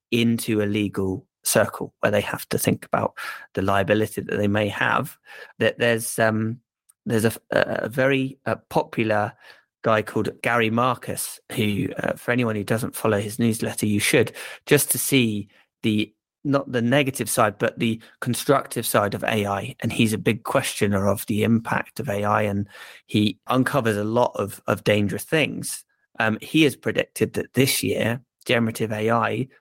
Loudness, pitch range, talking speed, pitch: -23 LUFS, 105-120 Hz, 165 wpm, 115 Hz